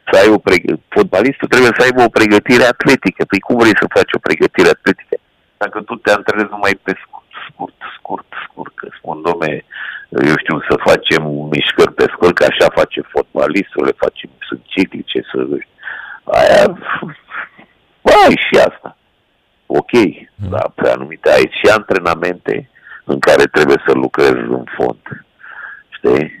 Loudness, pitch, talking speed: -12 LUFS, 355 Hz, 150 wpm